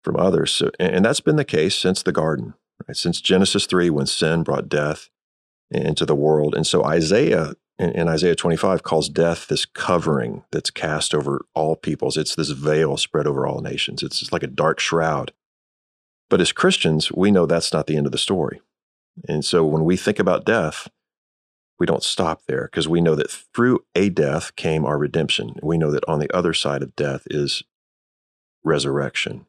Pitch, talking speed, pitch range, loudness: 80 Hz, 190 wpm, 75-85 Hz, -20 LUFS